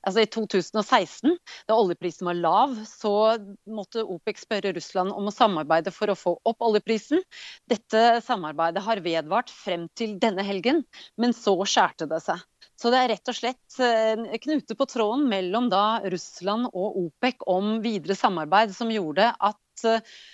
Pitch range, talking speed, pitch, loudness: 195-235 Hz, 155 wpm, 220 Hz, -25 LUFS